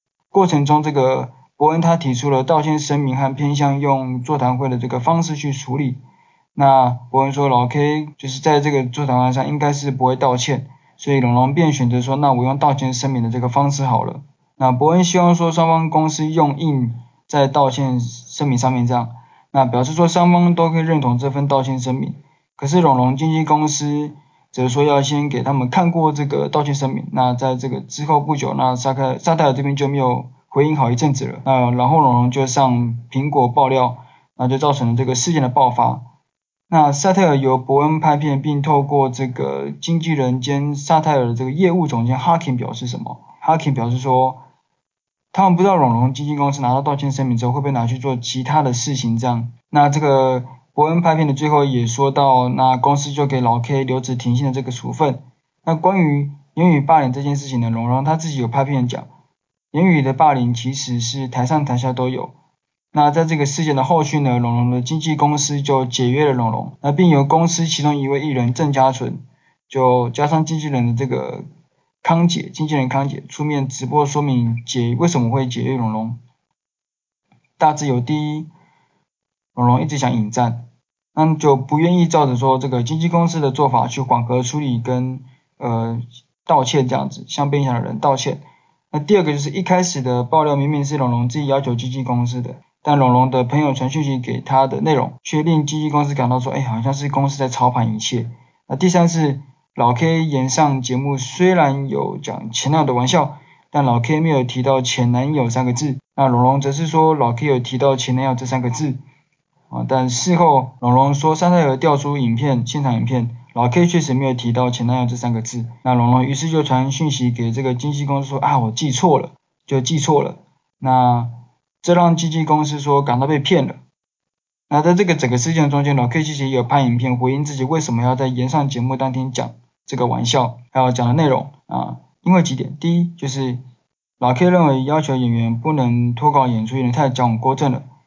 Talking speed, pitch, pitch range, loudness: 305 characters per minute, 135 Hz, 125-150 Hz, -17 LUFS